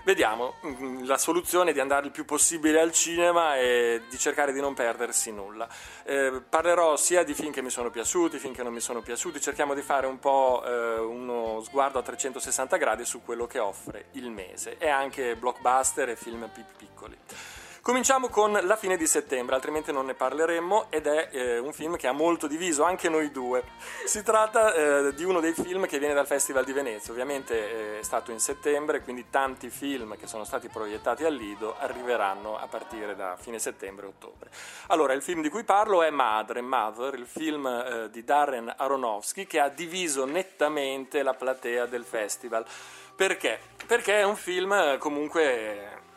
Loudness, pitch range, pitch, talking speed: -27 LUFS, 130-175 Hz, 145 Hz, 185 wpm